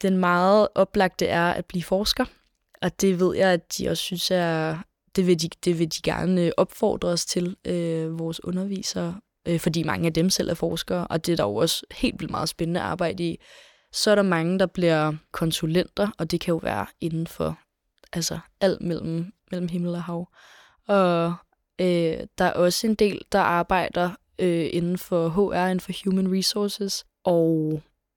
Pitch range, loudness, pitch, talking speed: 170-190 Hz, -24 LUFS, 175 Hz, 185 wpm